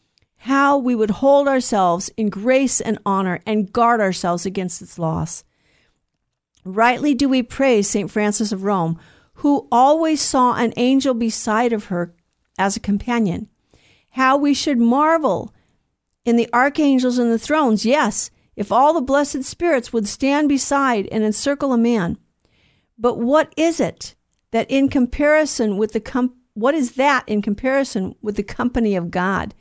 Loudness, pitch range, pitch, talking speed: -18 LUFS, 210-275 Hz, 235 Hz, 155 wpm